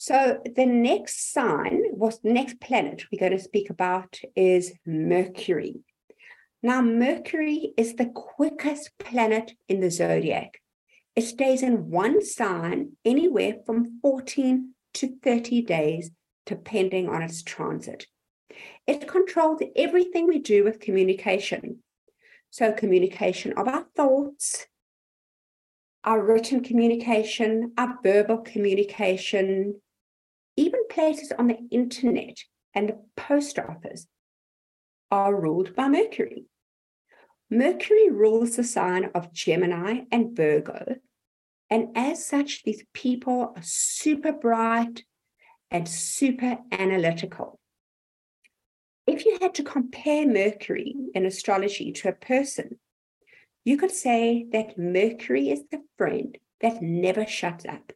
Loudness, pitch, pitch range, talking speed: -25 LUFS, 230 Hz, 195-275 Hz, 115 wpm